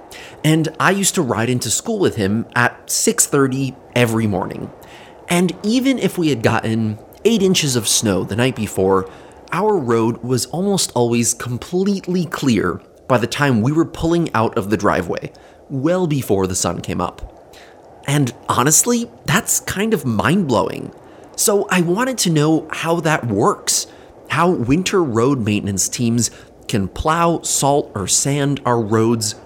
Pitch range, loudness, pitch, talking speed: 115-170 Hz, -17 LUFS, 135 Hz, 155 wpm